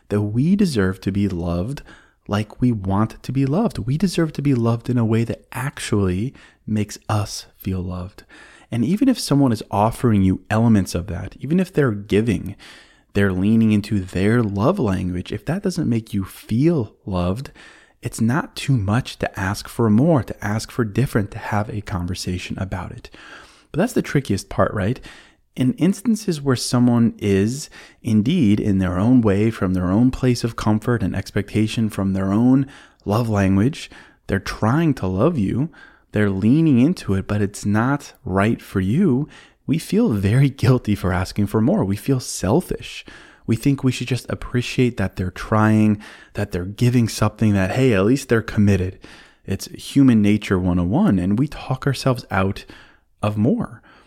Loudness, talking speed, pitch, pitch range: -20 LUFS, 175 wpm, 110 Hz, 100-125 Hz